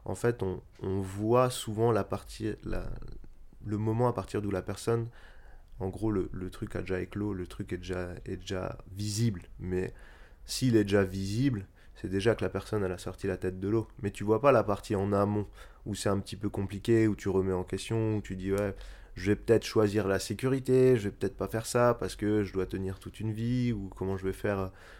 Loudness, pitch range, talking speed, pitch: -31 LUFS, 95-110 Hz, 230 wpm, 100 Hz